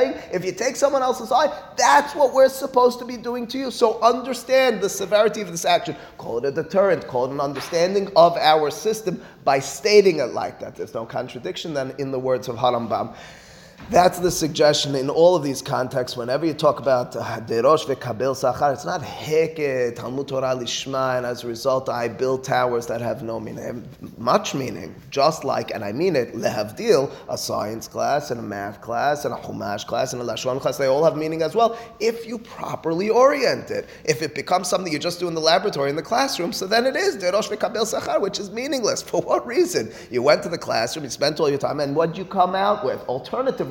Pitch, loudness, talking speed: 165 Hz, -21 LUFS, 210 wpm